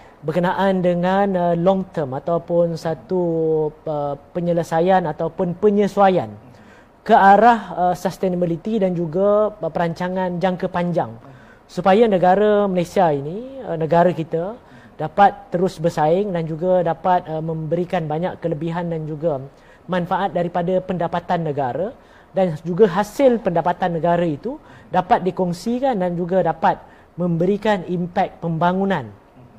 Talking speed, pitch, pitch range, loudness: 115 wpm, 175 Hz, 165-190 Hz, -19 LUFS